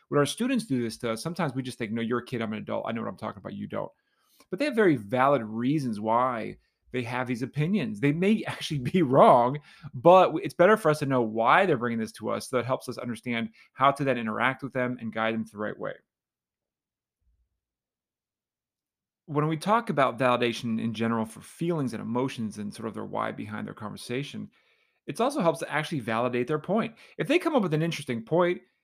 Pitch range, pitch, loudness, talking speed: 115-160 Hz, 130 Hz, -27 LUFS, 225 wpm